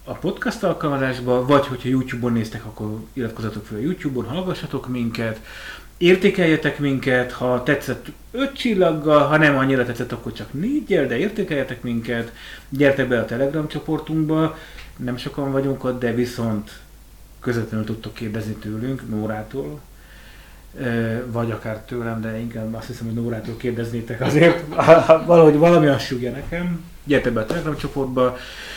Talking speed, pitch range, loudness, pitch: 140 wpm, 115-150 Hz, -20 LUFS, 125 Hz